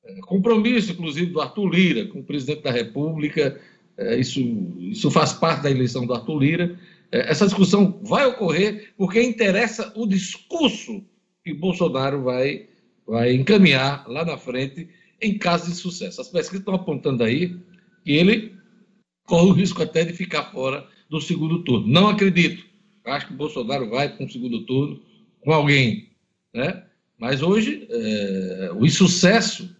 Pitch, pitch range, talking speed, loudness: 175 Hz, 145-200 Hz, 150 wpm, -21 LUFS